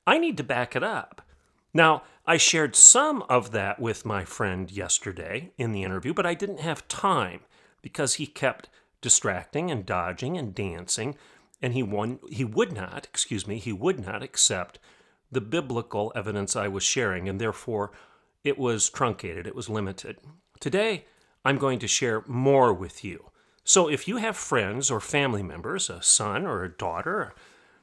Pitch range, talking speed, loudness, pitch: 105-155 Hz, 175 wpm, -24 LUFS, 125 Hz